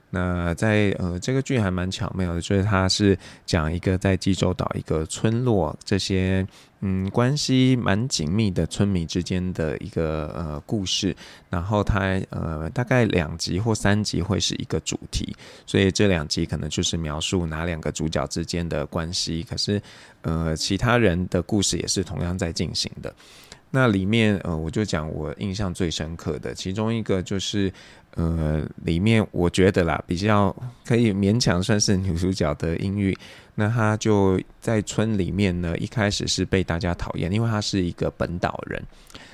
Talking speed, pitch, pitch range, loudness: 255 characters per minute, 95 Hz, 85-105 Hz, -24 LUFS